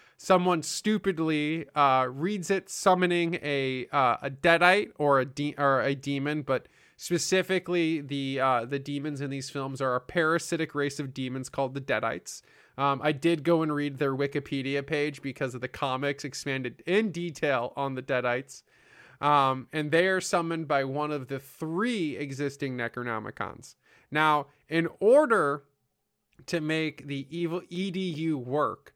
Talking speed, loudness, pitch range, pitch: 155 wpm, -28 LUFS, 135-165 Hz, 145 Hz